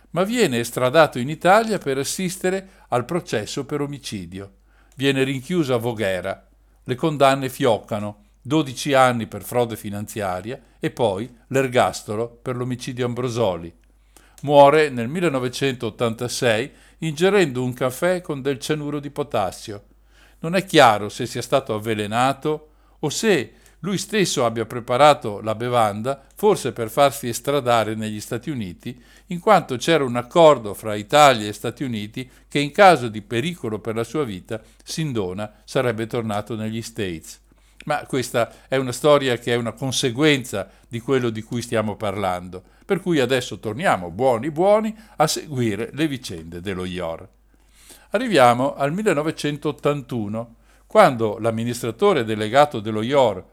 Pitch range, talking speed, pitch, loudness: 110-145 Hz, 135 wpm, 125 Hz, -21 LUFS